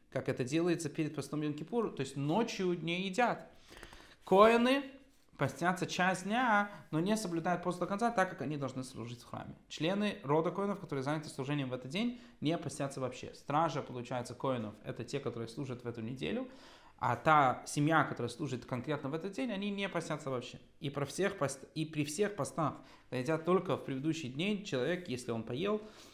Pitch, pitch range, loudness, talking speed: 155 Hz, 130-195 Hz, -35 LUFS, 185 wpm